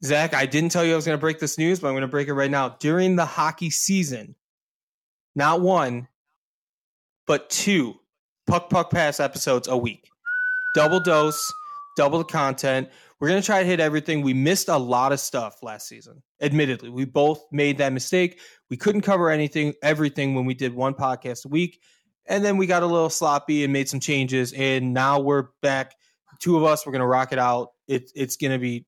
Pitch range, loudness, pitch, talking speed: 135-170 Hz, -22 LUFS, 150 Hz, 210 wpm